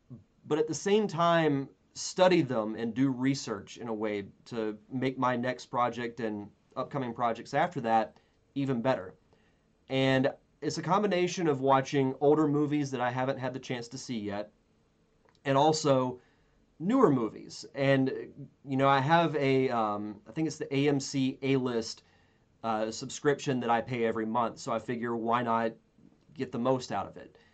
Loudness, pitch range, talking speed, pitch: -30 LUFS, 115-140 Hz, 170 wpm, 130 Hz